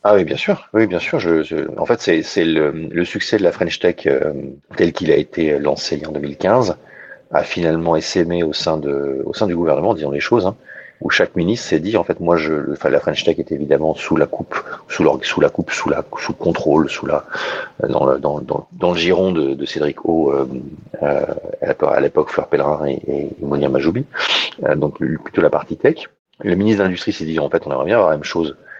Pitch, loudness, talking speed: 85 Hz, -18 LUFS, 235 wpm